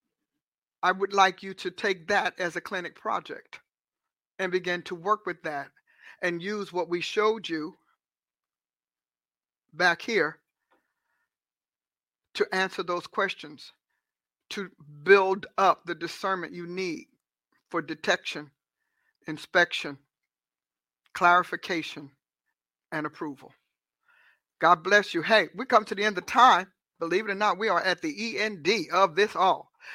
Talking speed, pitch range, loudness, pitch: 130 wpm, 140-200 Hz, -26 LUFS, 180 Hz